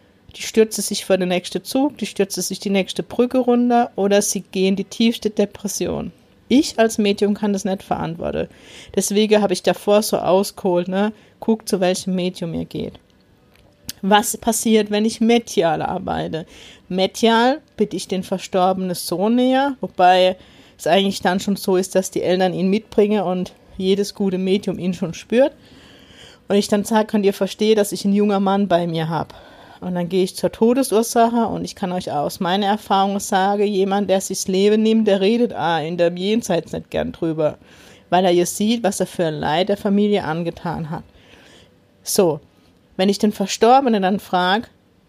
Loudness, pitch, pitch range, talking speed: -19 LUFS, 200 Hz, 185-215 Hz, 180 wpm